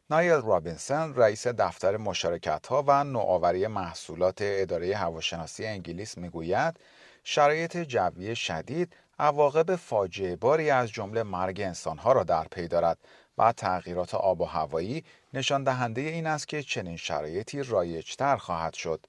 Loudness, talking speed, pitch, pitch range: -28 LUFS, 130 wpm, 115 Hz, 90-145 Hz